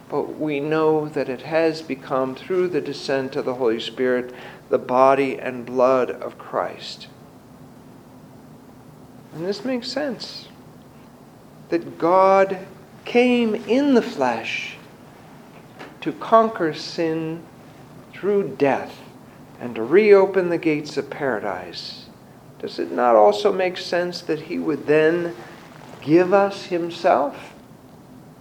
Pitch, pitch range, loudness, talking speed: 155 Hz, 130-190 Hz, -21 LUFS, 115 wpm